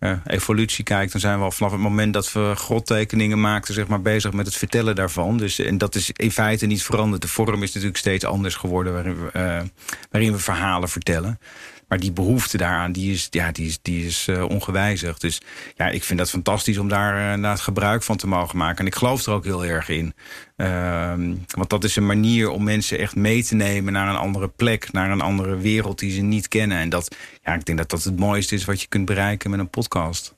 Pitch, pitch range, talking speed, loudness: 100 Hz, 90-105 Hz, 235 wpm, -22 LUFS